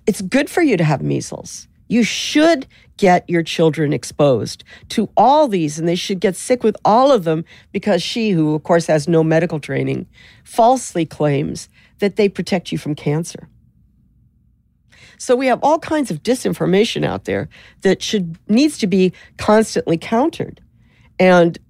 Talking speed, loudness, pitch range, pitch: 165 wpm, -17 LUFS, 160-235 Hz, 190 Hz